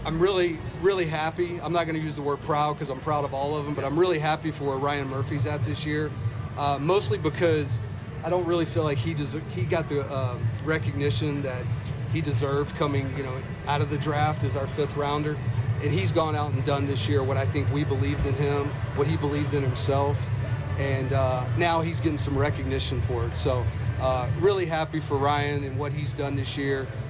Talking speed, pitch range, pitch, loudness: 220 wpm, 125-150 Hz, 140 Hz, -26 LUFS